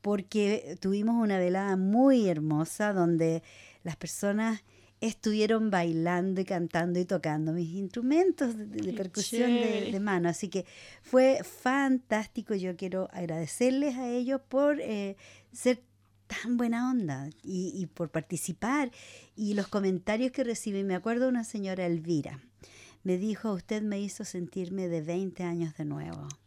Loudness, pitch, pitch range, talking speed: -30 LUFS, 195 Hz, 175-225 Hz, 145 wpm